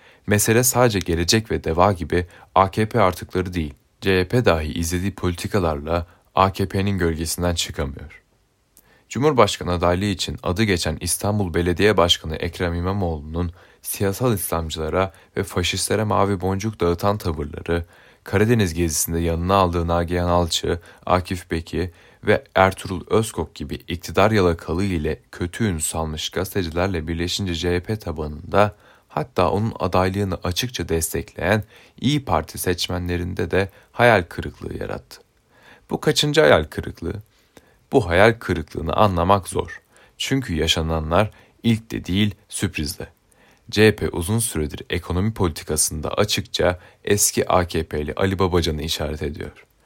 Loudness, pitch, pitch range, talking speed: -21 LUFS, 90 Hz, 85-100 Hz, 115 wpm